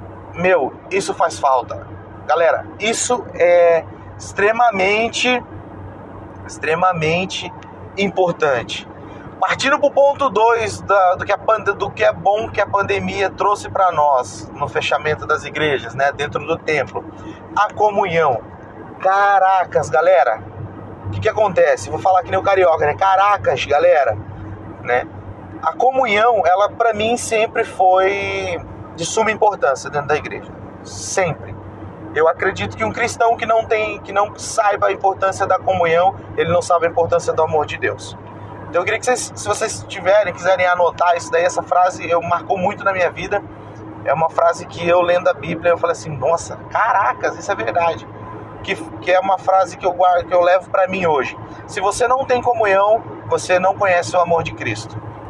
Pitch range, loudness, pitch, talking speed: 140-200 Hz, -17 LUFS, 175 Hz, 165 wpm